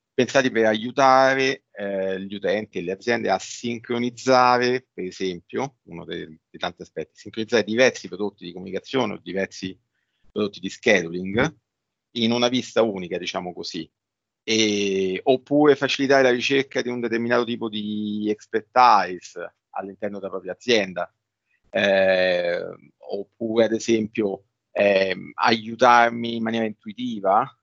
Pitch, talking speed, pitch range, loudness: 110 Hz, 125 wpm, 95-120 Hz, -22 LUFS